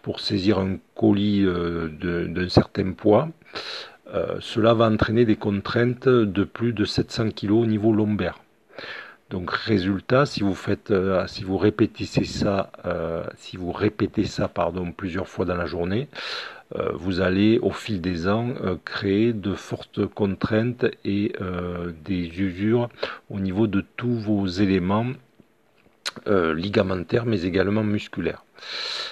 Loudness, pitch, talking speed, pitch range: -24 LUFS, 105 Hz, 145 wpm, 95-115 Hz